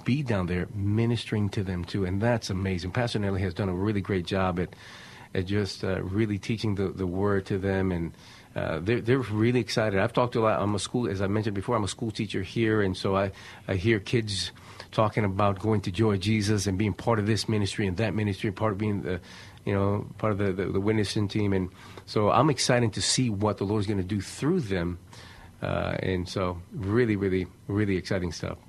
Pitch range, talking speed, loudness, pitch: 95-110 Hz, 225 wpm, -28 LUFS, 100 Hz